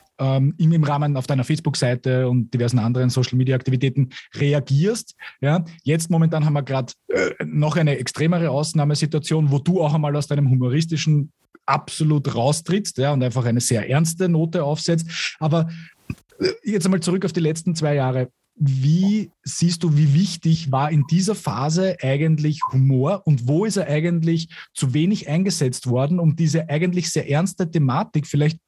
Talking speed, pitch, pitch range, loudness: 155 wpm, 150 Hz, 135-170 Hz, -20 LUFS